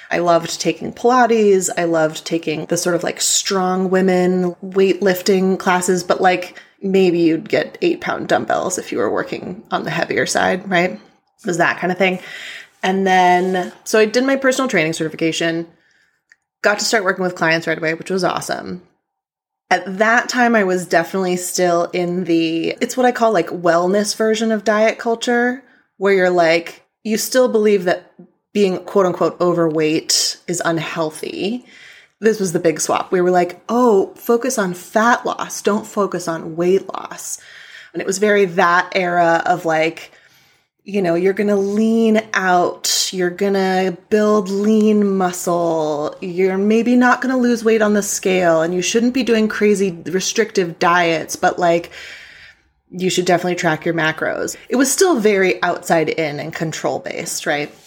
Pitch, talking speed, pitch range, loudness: 185 Hz, 170 wpm, 175-215 Hz, -17 LUFS